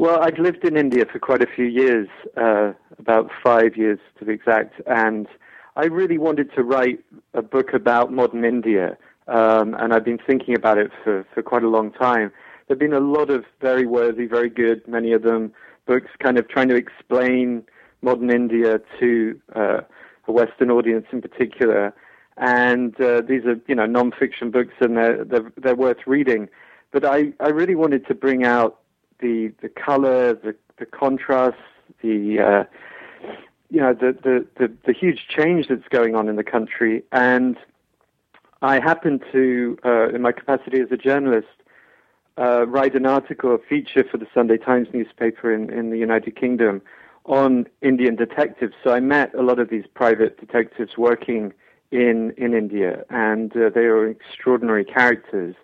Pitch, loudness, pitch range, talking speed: 120 Hz, -19 LUFS, 115-130 Hz, 175 wpm